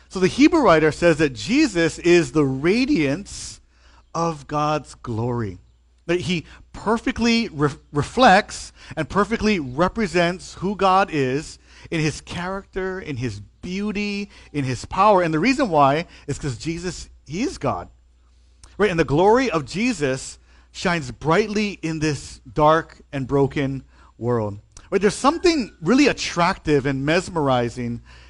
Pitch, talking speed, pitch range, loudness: 160 Hz, 135 wpm, 130-190 Hz, -21 LUFS